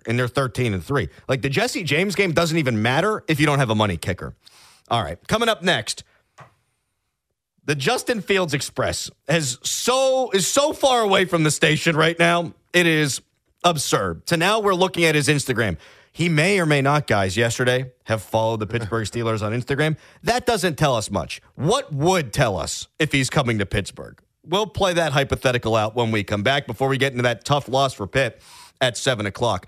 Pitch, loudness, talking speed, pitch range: 140 Hz, -21 LUFS, 200 wpm, 115-170 Hz